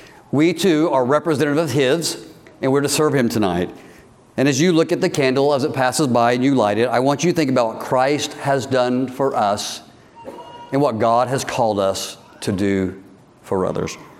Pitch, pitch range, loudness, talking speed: 135 Hz, 120-150 Hz, -18 LUFS, 205 wpm